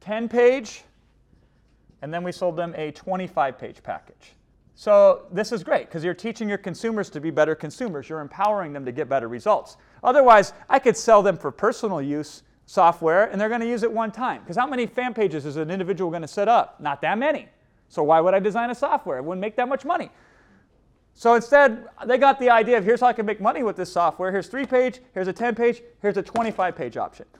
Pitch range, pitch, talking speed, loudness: 170-240 Hz, 210 Hz, 220 wpm, -22 LUFS